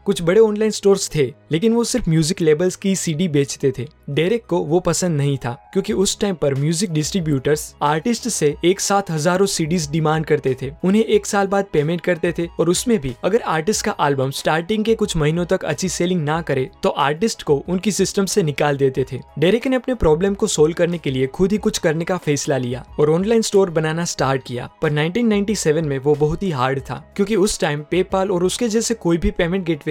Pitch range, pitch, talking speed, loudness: 150-200 Hz, 175 Hz, 220 wpm, -19 LUFS